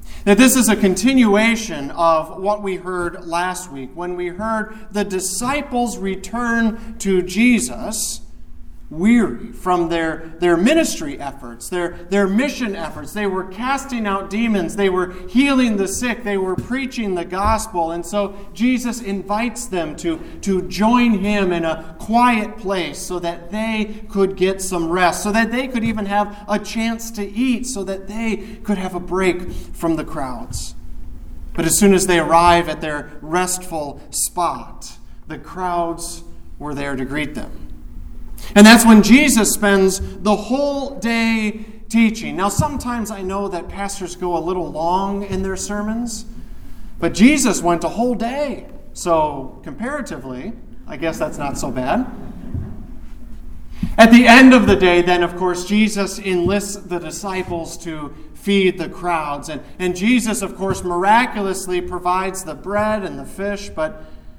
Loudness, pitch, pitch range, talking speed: -18 LUFS, 195 Hz, 170-220 Hz, 155 wpm